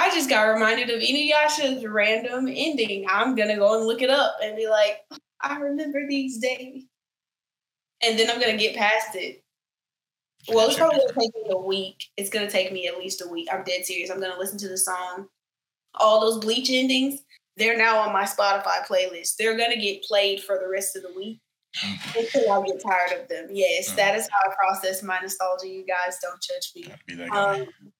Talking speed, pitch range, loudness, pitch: 200 wpm, 190-255 Hz, -23 LUFS, 215 Hz